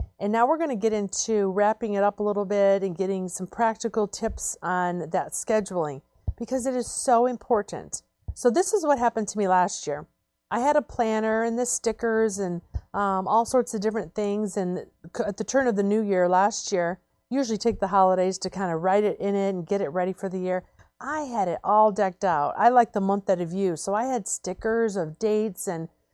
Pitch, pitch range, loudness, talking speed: 205 Hz, 190-225 Hz, -25 LUFS, 225 wpm